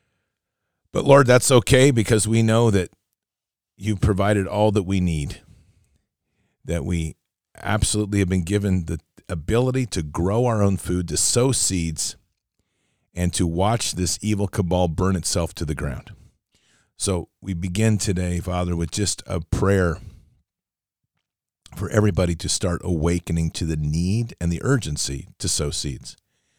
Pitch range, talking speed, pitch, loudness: 85-105 Hz, 145 wpm, 95 Hz, -21 LUFS